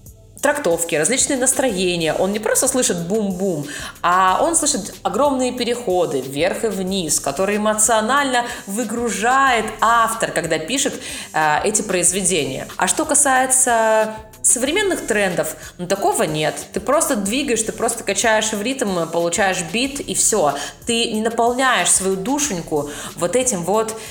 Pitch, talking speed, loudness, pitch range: 220 Hz, 130 wpm, -18 LUFS, 185-255 Hz